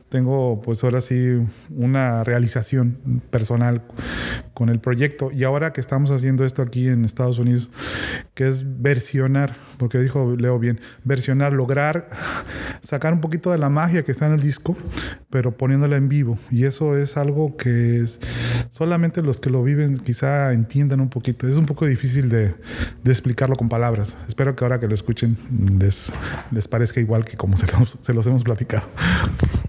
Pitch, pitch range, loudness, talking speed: 125 Hz, 120-140 Hz, -21 LUFS, 175 wpm